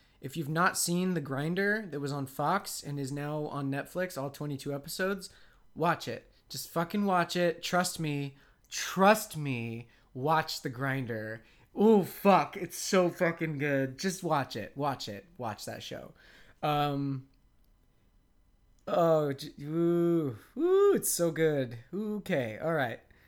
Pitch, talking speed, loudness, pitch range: 155 Hz, 145 wpm, -31 LUFS, 140-180 Hz